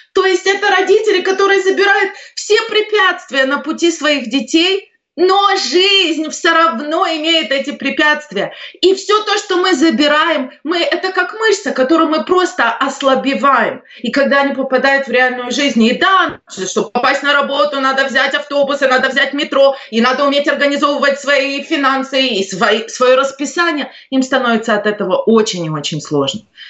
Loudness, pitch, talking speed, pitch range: -13 LUFS, 285 Hz, 155 wpm, 265-365 Hz